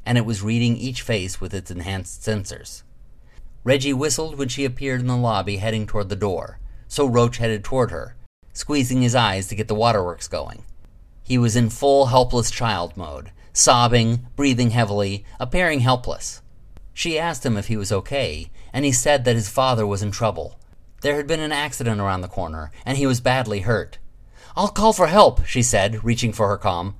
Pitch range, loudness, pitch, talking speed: 100-130 Hz, -21 LUFS, 115 Hz, 190 wpm